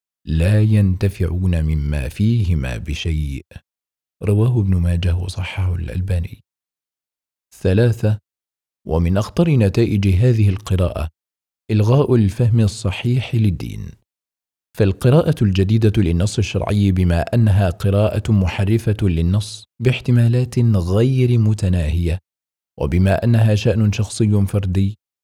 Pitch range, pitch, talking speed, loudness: 85-110 Hz, 100 Hz, 90 wpm, -18 LUFS